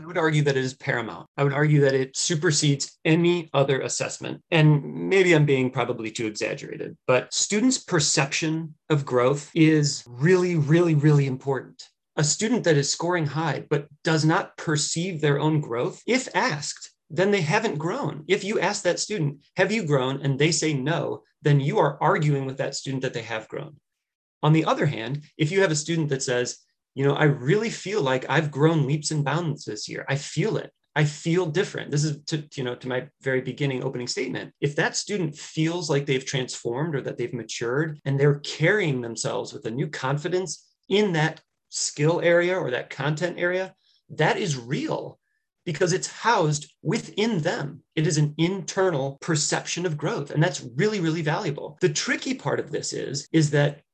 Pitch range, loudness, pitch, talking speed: 140-175 Hz, -24 LUFS, 155 Hz, 190 wpm